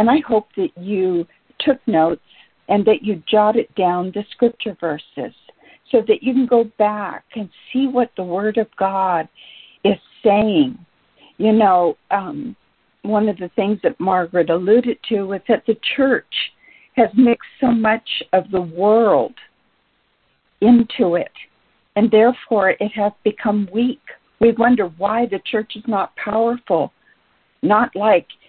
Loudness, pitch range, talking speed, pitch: -18 LUFS, 195-235 Hz, 145 wpm, 215 Hz